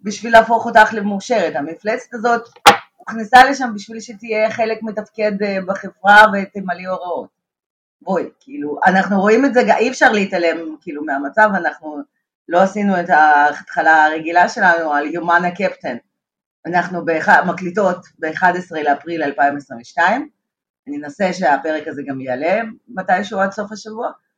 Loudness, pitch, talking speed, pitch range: -15 LUFS, 190 Hz, 130 wpm, 160-220 Hz